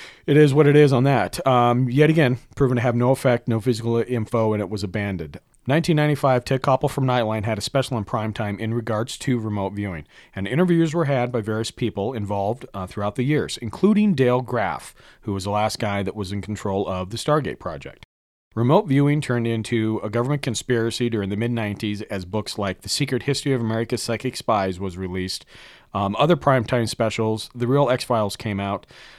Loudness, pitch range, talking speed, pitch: -22 LUFS, 105-130 Hz, 200 wpm, 115 Hz